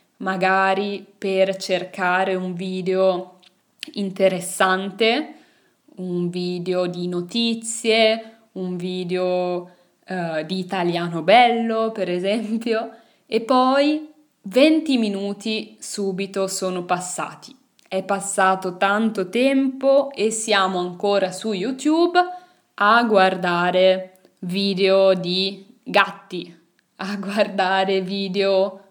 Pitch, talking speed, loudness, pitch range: 195 Hz, 85 wpm, -20 LUFS, 185-225 Hz